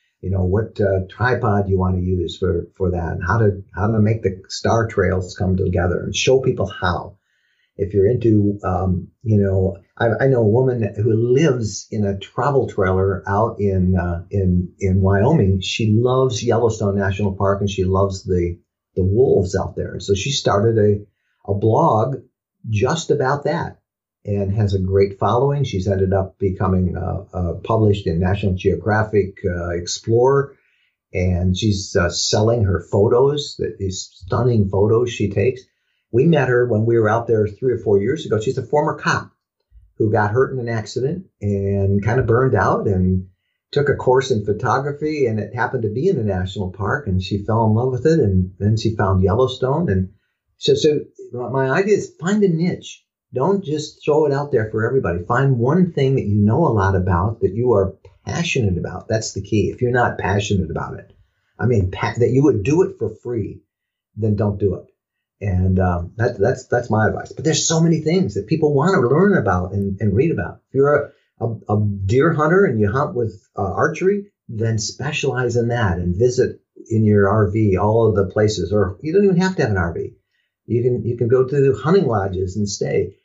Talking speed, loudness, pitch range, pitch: 200 wpm, -19 LUFS, 95-125 Hz, 105 Hz